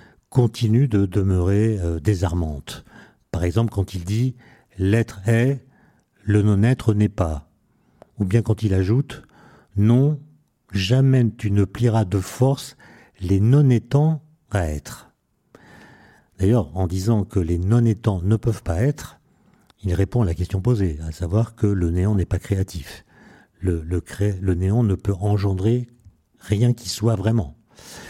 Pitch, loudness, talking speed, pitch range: 105 Hz, -21 LUFS, 145 wpm, 95-120 Hz